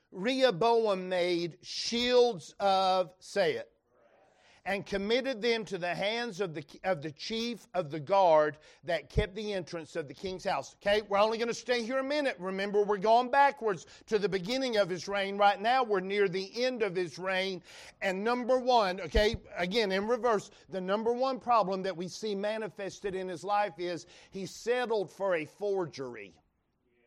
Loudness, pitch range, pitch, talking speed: -31 LUFS, 180-230 Hz, 200 Hz, 175 wpm